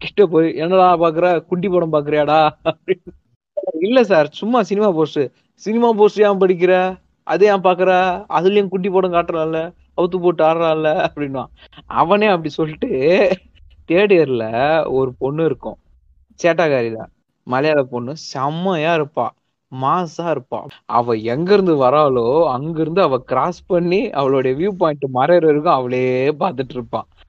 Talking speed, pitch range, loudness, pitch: 130 wpm, 135-185 Hz, -17 LUFS, 160 Hz